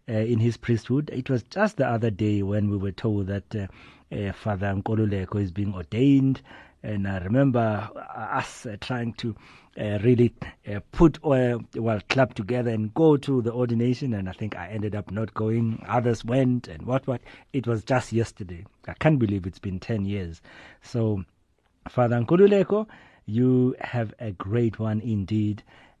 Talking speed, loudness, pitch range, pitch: 170 wpm, -25 LUFS, 105-125 Hz, 115 Hz